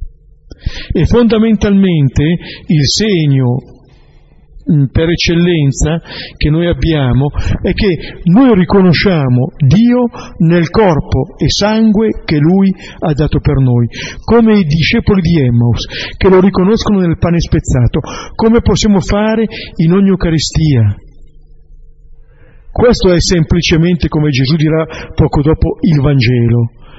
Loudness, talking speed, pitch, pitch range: -11 LUFS, 115 wpm, 165 Hz, 140-195 Hz